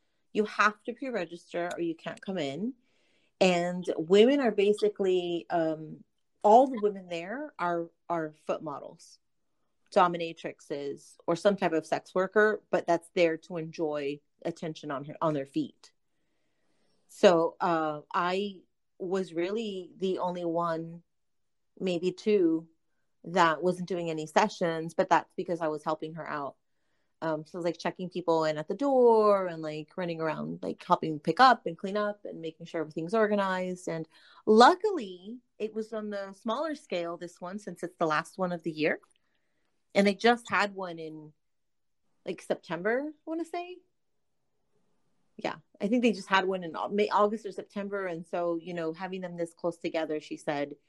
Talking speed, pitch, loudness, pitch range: 170 wpm, 180 Hz, -29 LUFS, 165-205 Hz